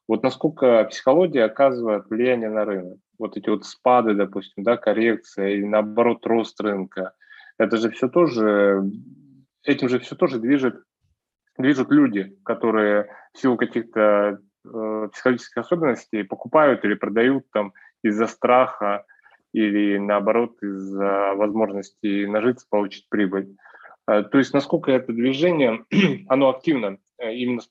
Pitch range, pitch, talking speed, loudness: 100-125 Hz, 110 Hz, 130 wpm, -21 LUFS